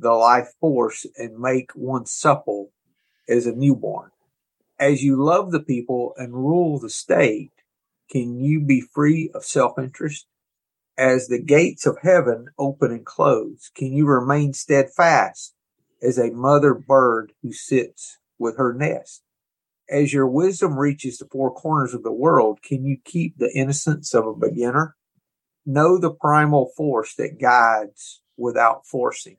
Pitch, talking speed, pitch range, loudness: 140 Hz, 150 wpm, 125-155 Hz, -20 LUFS